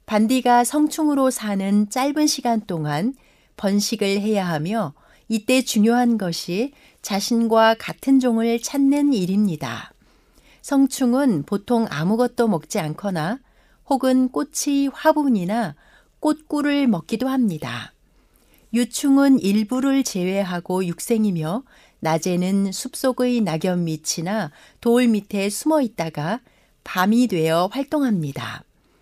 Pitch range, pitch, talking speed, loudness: 185-260 Hz, 225 Hz, 240 characters per minute, -21 LUFS